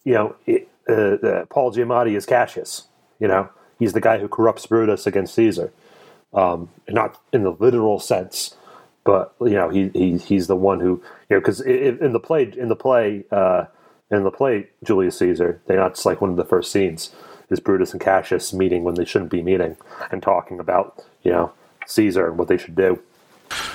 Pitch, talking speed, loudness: 115 Hz, 200 wpm, -20 LUFS